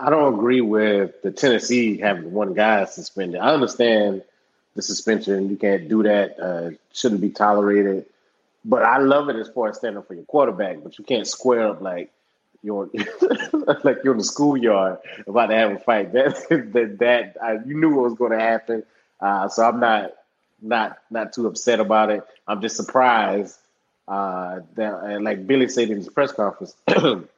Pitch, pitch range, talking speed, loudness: 110 Hz, 100-120 Hz, 180 wpm, -20 LUFS